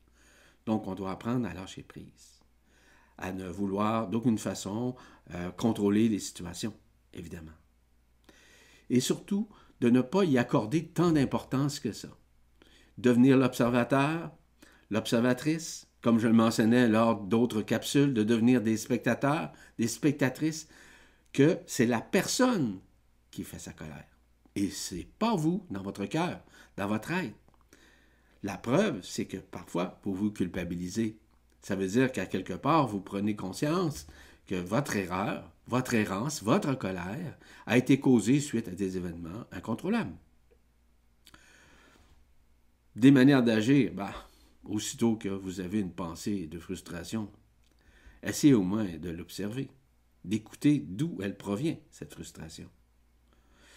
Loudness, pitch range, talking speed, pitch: -29 LUFS, 85-125 Hz, 130 wpm, 110 Hz